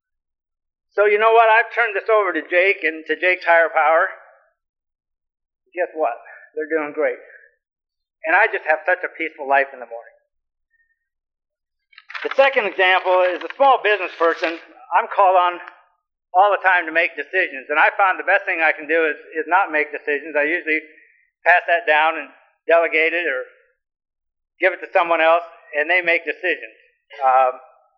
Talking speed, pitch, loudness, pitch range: 175 wpm, 170 Hz, -18 LUFS, 155-210 Hz